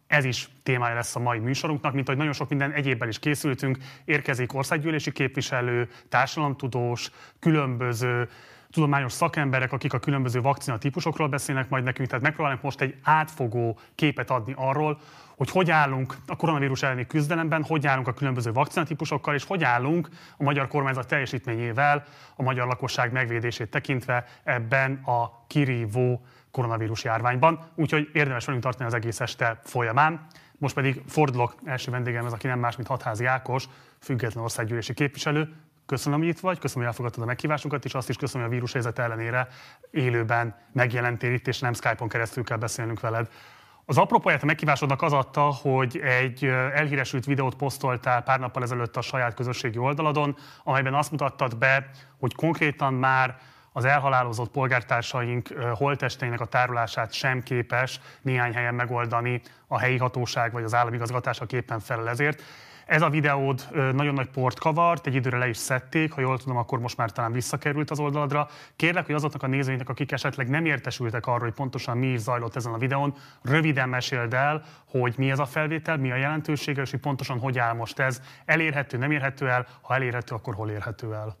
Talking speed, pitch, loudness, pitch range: 165 wpm, 130 Hz, -26 LUFS, 125-145 Hz